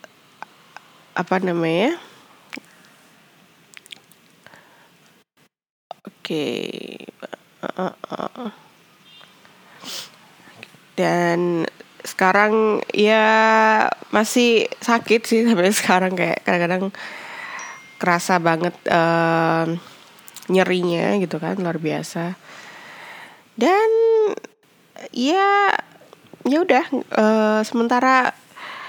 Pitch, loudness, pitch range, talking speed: 195 Hz, -19 LUFS, 175-235 Hz, 65 wpm